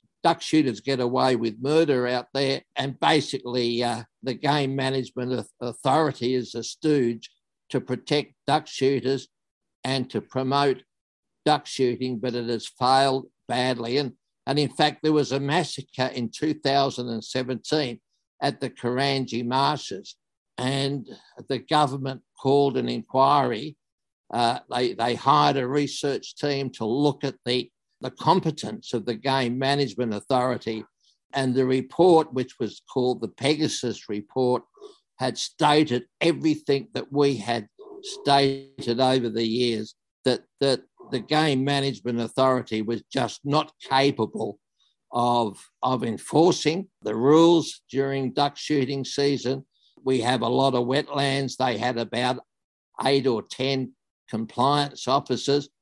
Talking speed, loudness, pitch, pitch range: 130 wpm, -25 LUFS, 130 Hz, 125-140 Hz